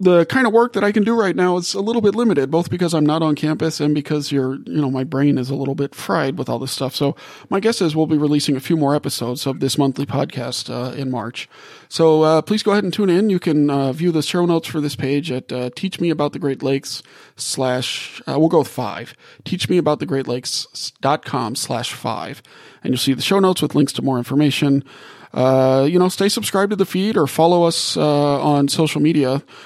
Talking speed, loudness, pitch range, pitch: 250 wpm, -18 LUFS, 135-175 Hz, 150 Hz